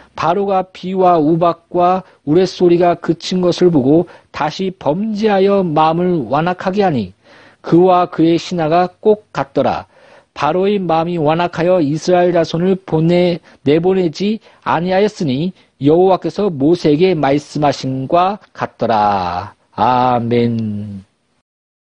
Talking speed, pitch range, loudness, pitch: 255 characters per minute, 145-185 Hz, -15 LUFS, 170 Hz